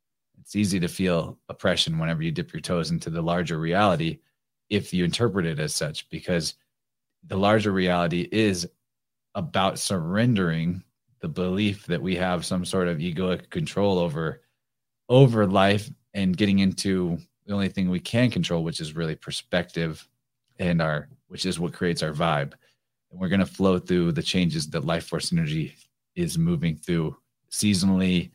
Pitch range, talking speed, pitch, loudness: 85-125 Hz, 165 wpm, 95 Hz, -25 LUFS